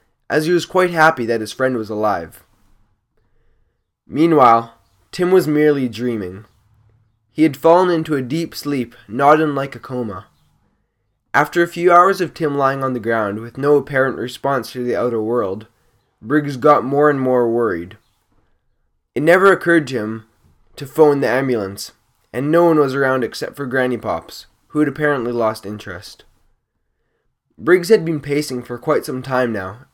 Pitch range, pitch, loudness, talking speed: 110-150 Hz, 130 Hz, -17 LUFS, 165 wpm